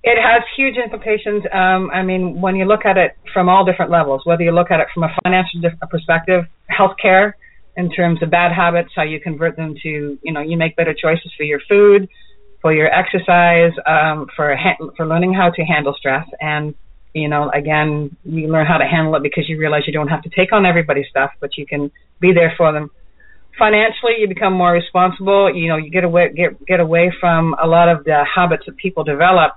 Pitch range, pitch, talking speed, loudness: 155-185 Hz, 170 Hz, 220 wpm, -15 LUFS